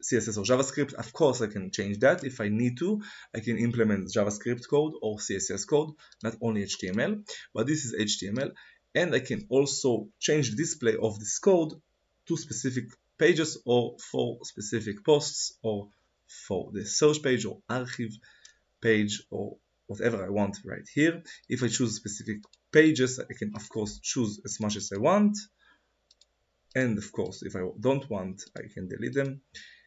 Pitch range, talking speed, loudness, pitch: 105-145 Hz, 170 wpm, -29 LUFS, 120 Hz